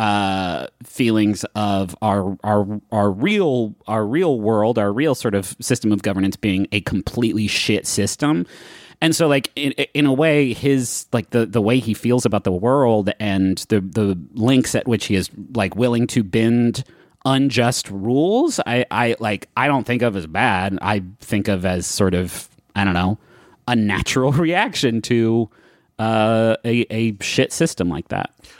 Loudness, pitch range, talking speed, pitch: -19 LUFS, 100-125 Hz, 170 wpm, 110 Hz